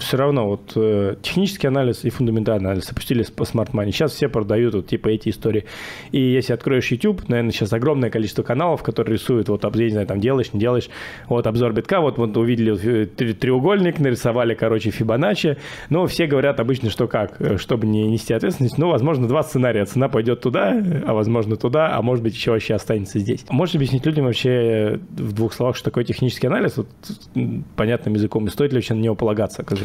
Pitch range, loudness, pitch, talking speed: 110-135 Hz, -20 LUFS, 120 Hz, 200 wpm